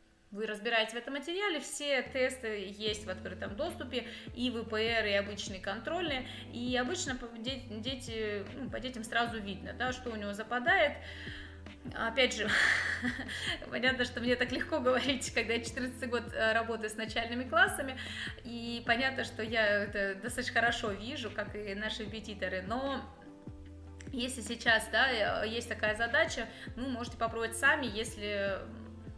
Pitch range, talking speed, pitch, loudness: 215-255 Hz, 140 wpm, 235 Hz, -33 LUFS